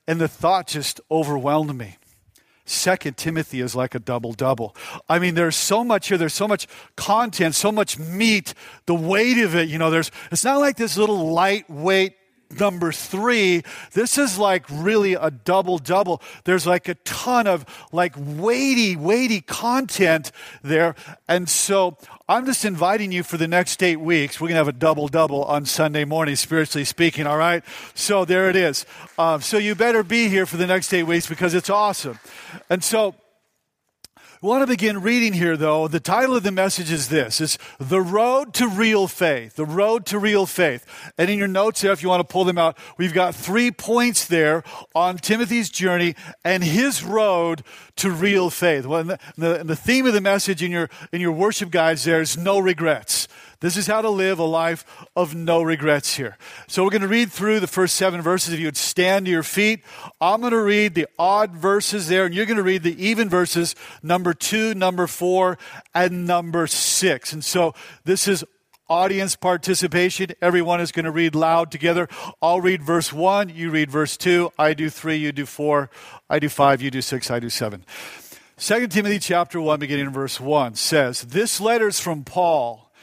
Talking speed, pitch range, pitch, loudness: 200 wpm, 160-200 Hz, 175 Hz, -20 LUFS